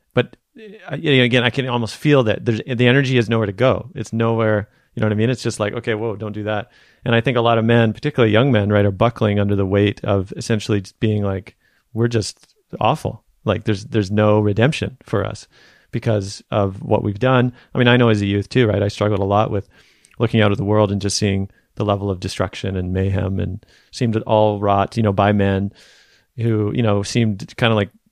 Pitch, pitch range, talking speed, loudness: 110 Hz, 100-120 Hz, 230 wpm, -18 LUFS